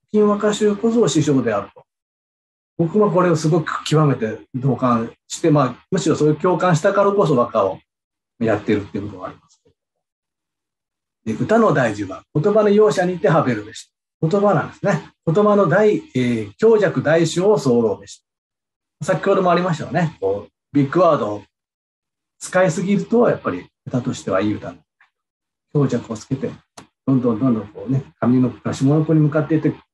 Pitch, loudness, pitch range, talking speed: 155 Hz, -18 LUFS, 125-195 Hz, 335 characters per minute